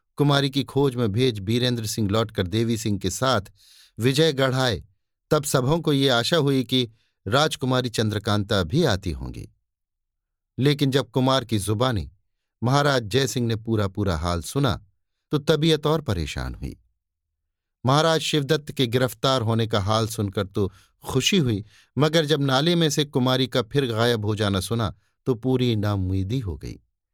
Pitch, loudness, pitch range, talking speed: 115 Hz, -23 LUFS, 100-135 Hz, 160 wpm